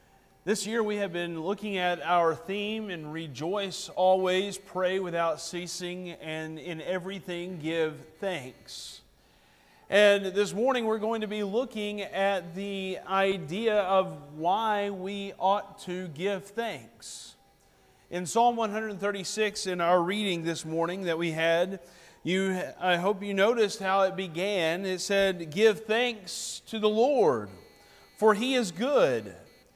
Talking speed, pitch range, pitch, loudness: 135 wpm, 175-205 Hz, 190 Hz, -28 LUFS